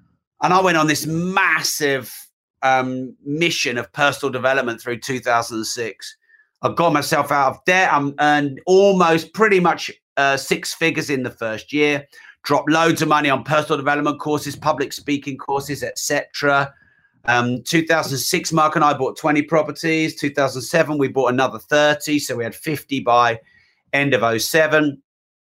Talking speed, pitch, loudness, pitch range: 175 wpm, 145 Hz, -18 LUFS, 135-160 Hz